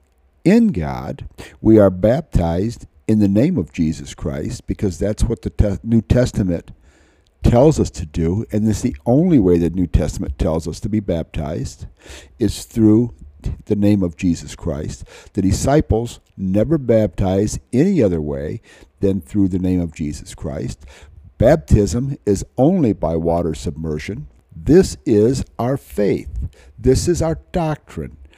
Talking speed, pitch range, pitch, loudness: 150 wpm, 80-110 Hz, 100 Hz, -18 LUFS